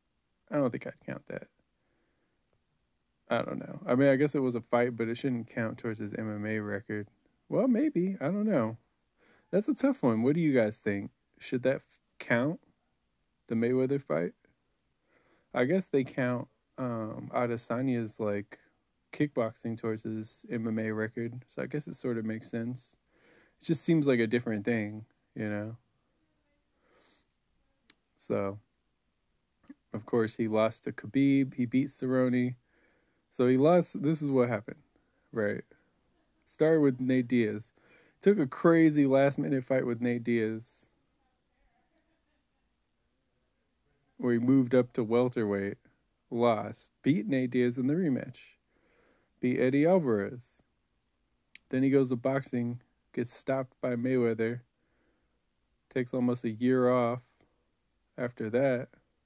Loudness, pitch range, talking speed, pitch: -30 LUFS, 110-135 Hz, 140 wpm, 120 Hz